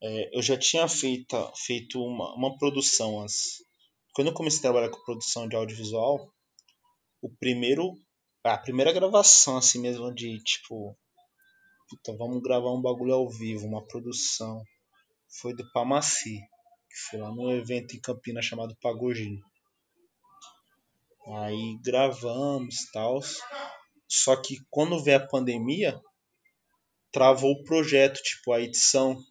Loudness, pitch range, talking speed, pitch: -26 LUFS, 115-145 Hz, 130 wpm, 125 Hz